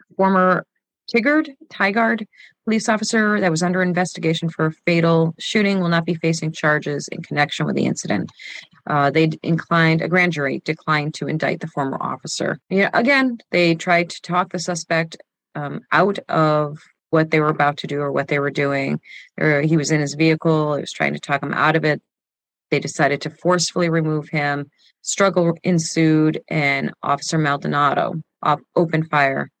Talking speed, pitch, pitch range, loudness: 170 wpm, 160 Hz, 150-180 Hz, -19 LUFS